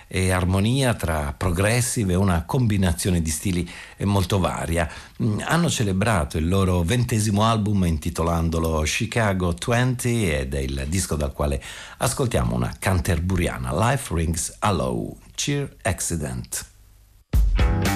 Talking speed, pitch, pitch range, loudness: 115 wpm, 95 Hz, 80-105 Hz, -23 LUFS